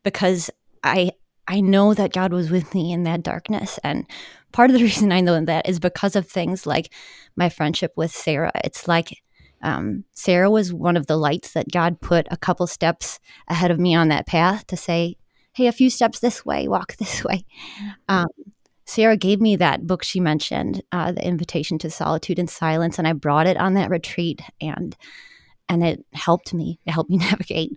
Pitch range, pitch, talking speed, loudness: 165-195 Hz, 180 Hz, 200 wpm, -21 LUFS